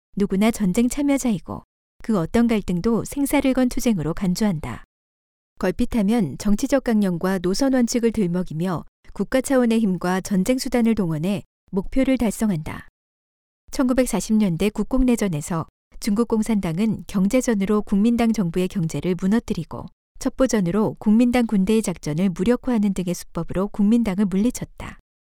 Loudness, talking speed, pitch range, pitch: -21 LUFS, 320 characters per minute, 180-235 Hz, 205 Hz